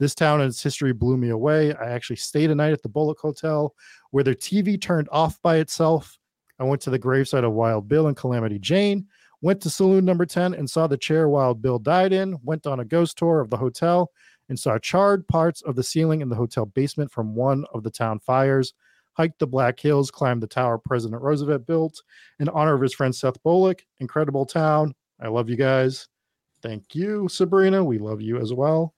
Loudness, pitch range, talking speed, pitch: -22 LUFS, 130-160 Hz, 215 wpm, 145 Hz